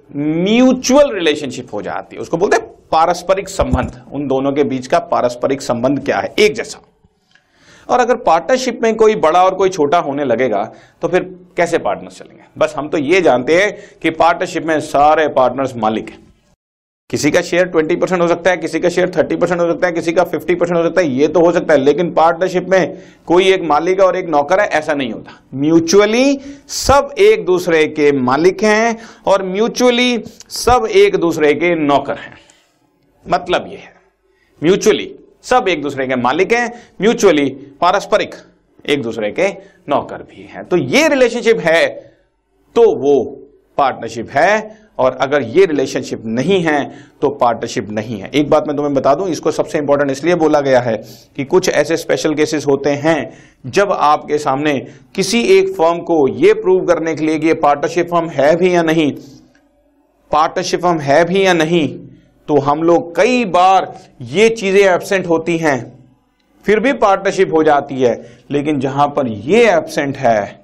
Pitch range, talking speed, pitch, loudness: 145-210 Hz, 180 wpm, 175 Hz, -14 LUFS